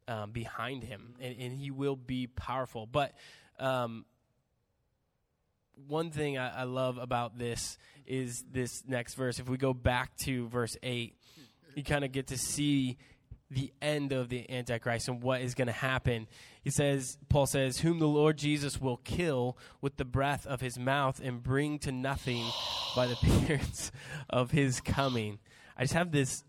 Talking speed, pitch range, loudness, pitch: 170 wpm, 120-140 Hz, -33 LUFS, 130 Hz